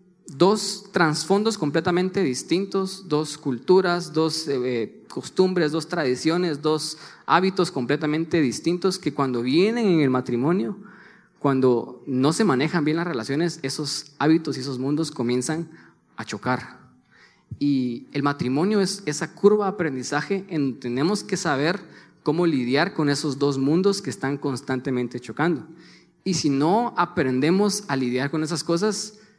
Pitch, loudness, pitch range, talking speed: 155 Hz, -23 LUFS, 140-180 Hz, 135 wpm